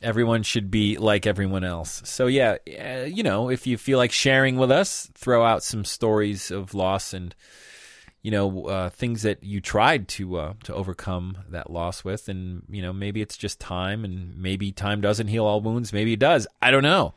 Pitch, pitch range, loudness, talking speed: 105 Hz, 95-115 Hz, -24 LUFS, 205 wpm